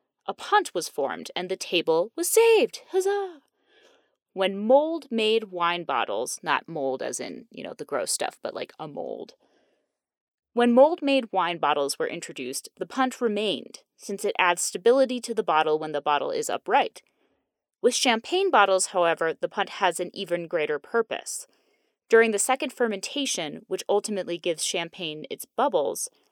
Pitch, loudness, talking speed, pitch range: 210 Hz, -25 LUFS, 160 wpm, 175-290 Hz